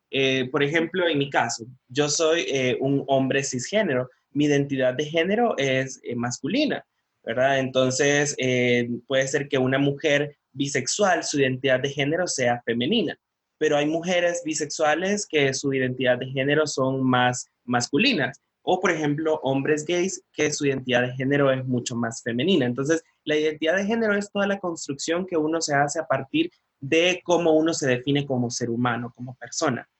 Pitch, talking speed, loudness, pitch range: 140 Hz, 170 wpm, -23 LUFS, 130-160 Hz